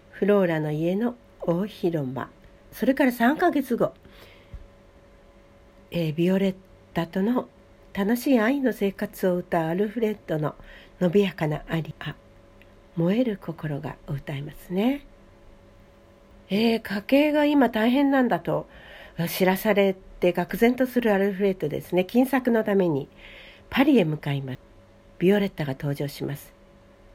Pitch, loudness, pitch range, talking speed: 180 Hz, -24 LUFS, 140-220 Hz, 265 characters per minute